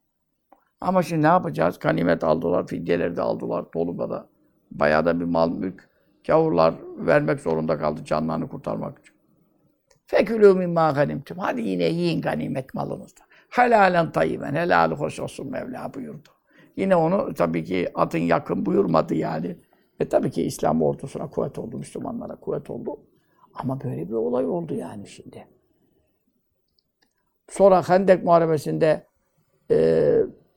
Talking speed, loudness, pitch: 130 wpm, -23 LUFS, 145 Hz